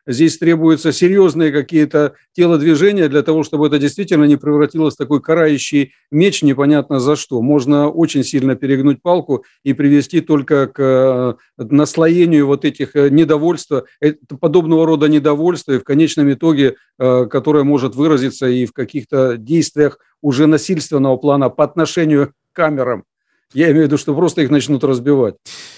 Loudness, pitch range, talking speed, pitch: -14 LUFS, 140-160 Hz, 145 wpm, 150 Hz